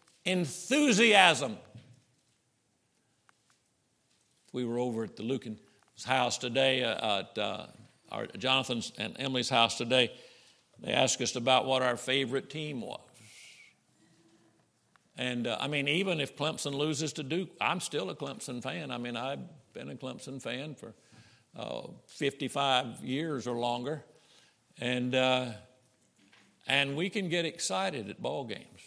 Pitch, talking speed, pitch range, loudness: 130 Hz, 135 wpm, 125-150 Hz, -30 LUFS